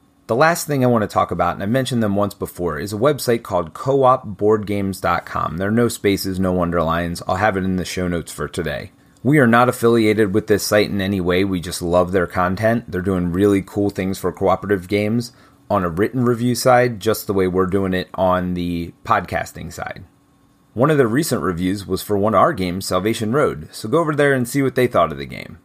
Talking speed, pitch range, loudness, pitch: 225 wpm, 90-115 Hz, -18 LUFS, 100 Hz